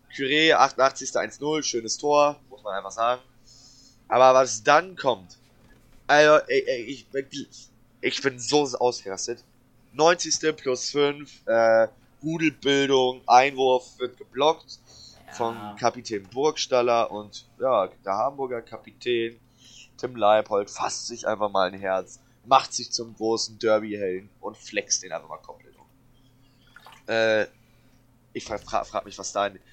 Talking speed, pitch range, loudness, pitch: 130 wpm, 115-135 Hz, -24 LUFS, 125 Hz